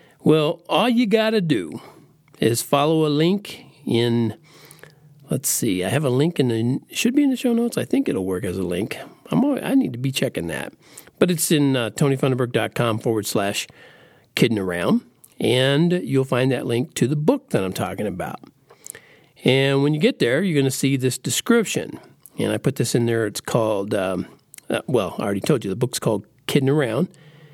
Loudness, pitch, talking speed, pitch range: -21 LUFS, 145 Hz, 200 wpm, 125-180 Hz